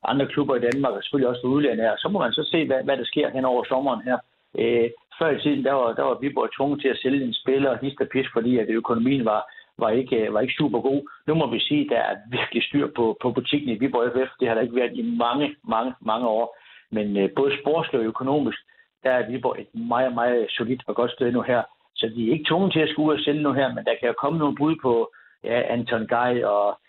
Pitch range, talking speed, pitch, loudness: 120-145 Hz, 265 wpm, 130 Hz, -23 LUFS